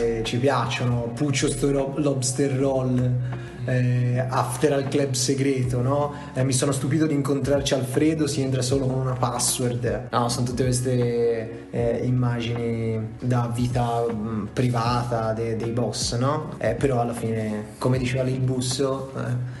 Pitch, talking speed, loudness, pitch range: 125 Hz, 145 wpm, -24 LUFS, 120-135 Hz